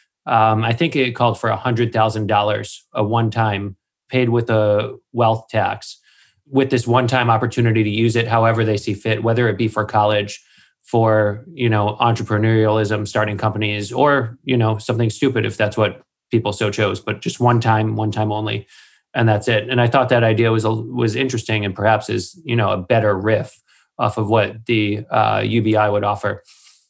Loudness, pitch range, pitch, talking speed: -18 LUFS, 105-120 Hz, 110 Hz, 190 wpm